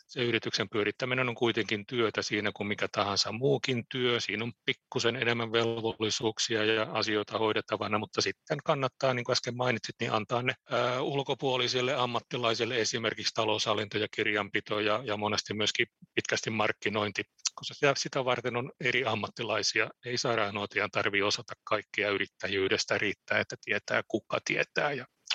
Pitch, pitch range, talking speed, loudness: 115 Hz, 110-125 Hz, 140 wpm, -30 LUFS